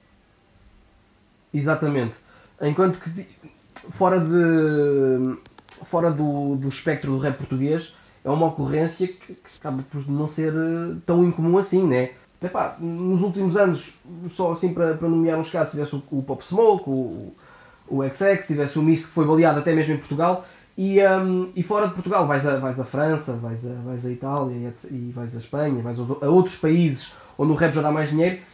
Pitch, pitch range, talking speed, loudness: 155 Hz, 135-175 Hz, 180 wpm, -22 LUFS